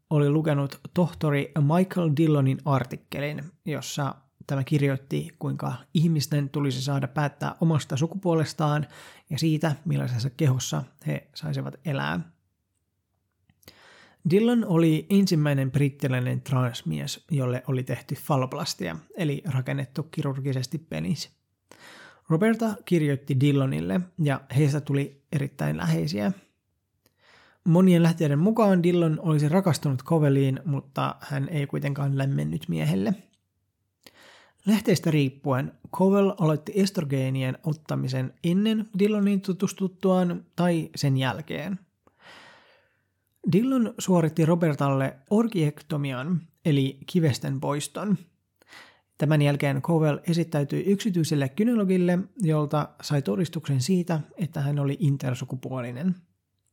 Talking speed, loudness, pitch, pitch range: 95 wpm, -26 LUFS, 150 Hz, 135-175 Hz